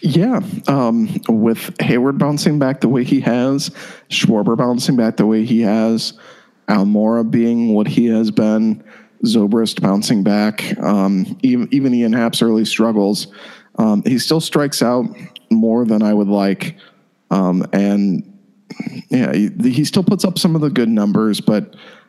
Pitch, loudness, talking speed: 115 Hz, -16 LUFS, 155 wpm